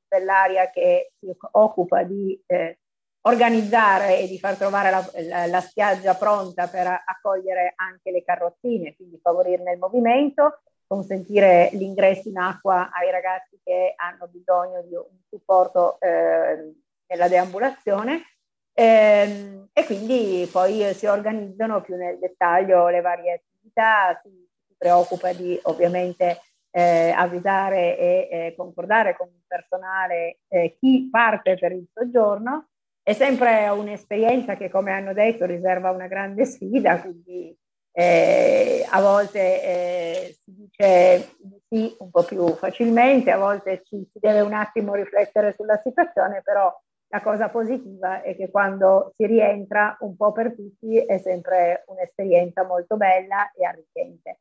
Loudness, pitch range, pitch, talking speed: -21 LUFS, 180-215 Hz, 190 Hz, 135 wpm